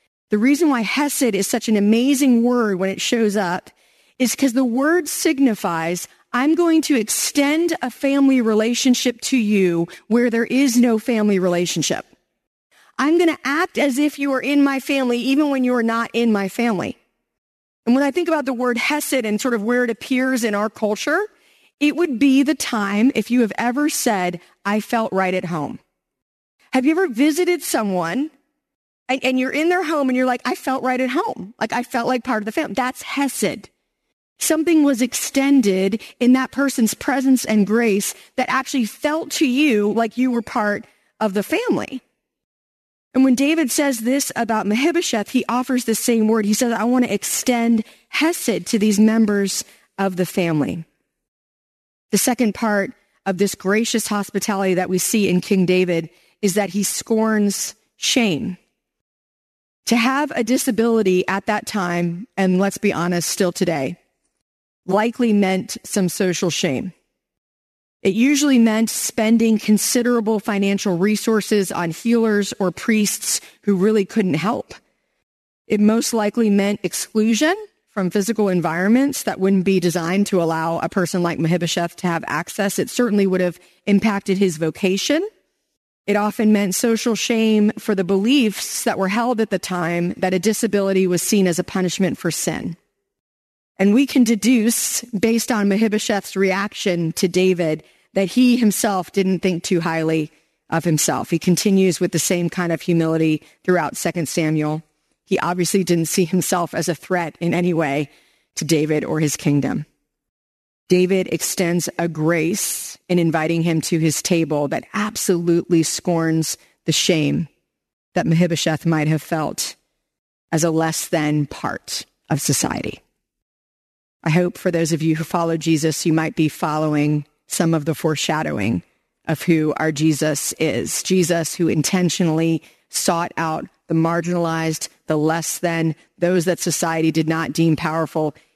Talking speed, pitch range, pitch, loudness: 160 wpm, 170-245 Hz, 205 Hz, -19 LUFS